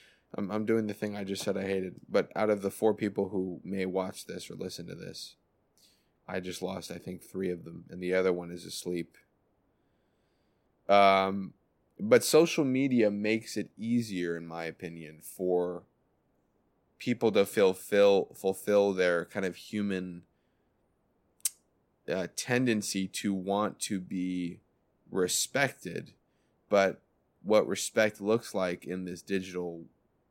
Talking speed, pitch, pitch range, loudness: 145 wpm, 95 Hz, 90-105 Hz, -30 LUFS